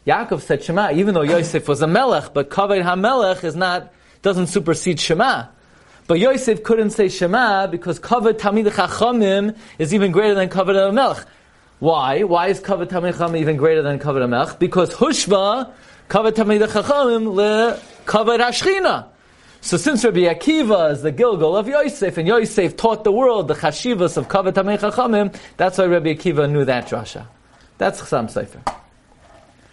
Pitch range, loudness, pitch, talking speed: 170-220 Hz, -18 LUFS, 195 Hz, 155 wpm